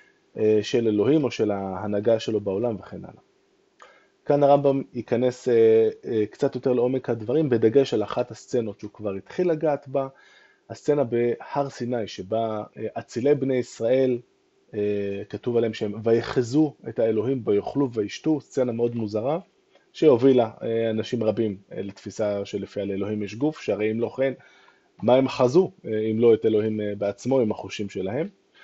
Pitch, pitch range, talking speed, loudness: 115 Hz, 105-135 Hz, 140 wpm, -24 LUFS